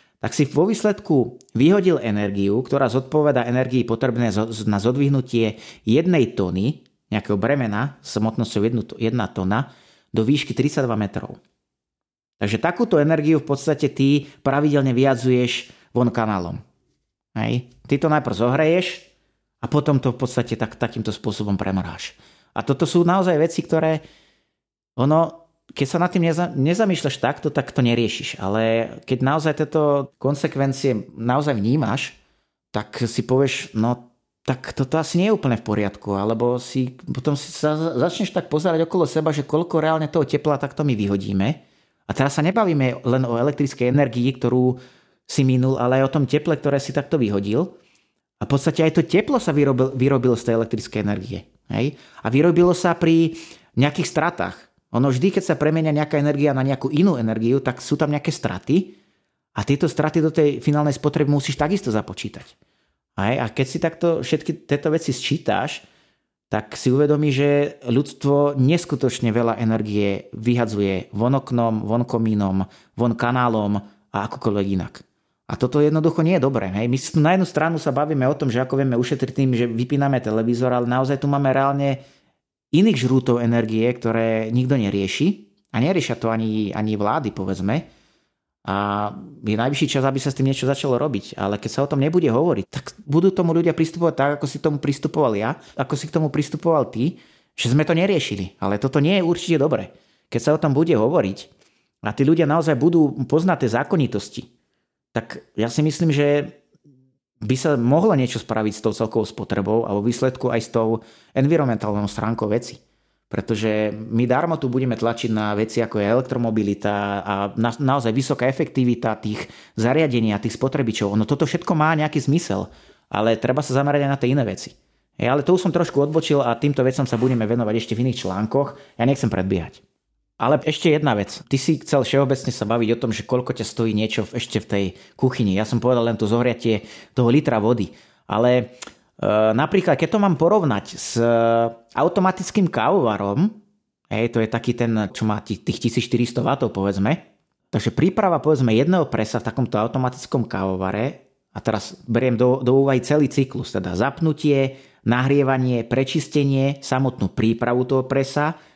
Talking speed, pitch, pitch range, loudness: 170 wpm, 130 Hz, 115-150 Hz, -21 LUFS